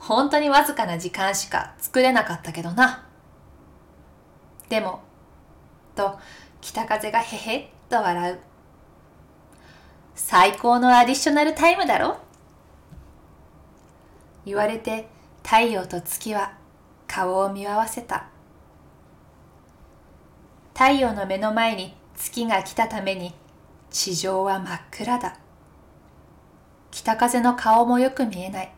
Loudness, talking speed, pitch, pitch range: -22 LUFS, 200 characters per minute, 195 Hz, 170-235 Hz